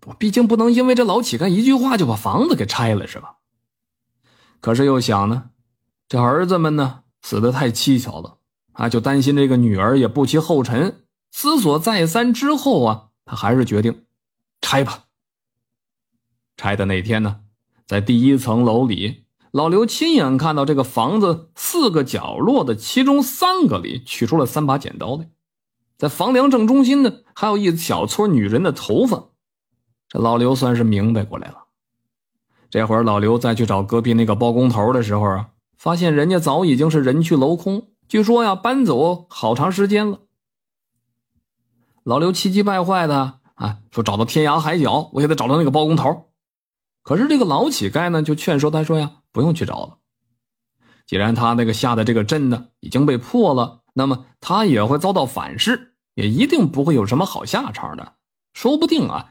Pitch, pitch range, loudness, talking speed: 135 Hz, 115-180 Hz, -18 LUFS, 260 characters per minute